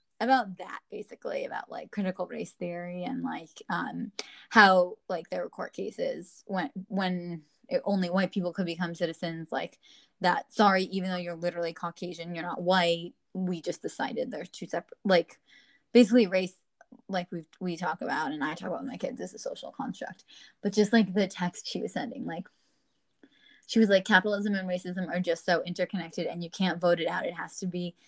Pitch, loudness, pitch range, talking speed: 185 Hz, -29 LUFS, 175-205 Hz, 195 wpm